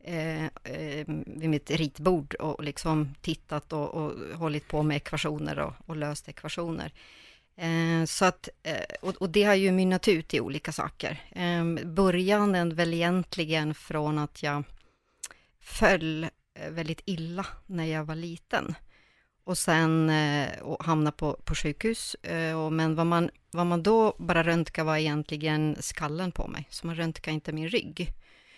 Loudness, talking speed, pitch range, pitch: -29 LUFS, 155 wpm, 155-175 Hz, 160 Hz